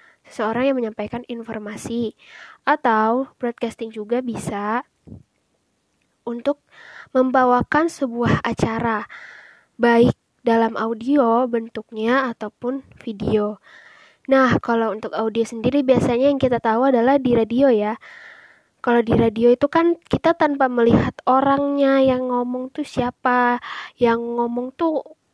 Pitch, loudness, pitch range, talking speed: 245 Hz, -20 LUFS, 230-270 Hz, 110 wpm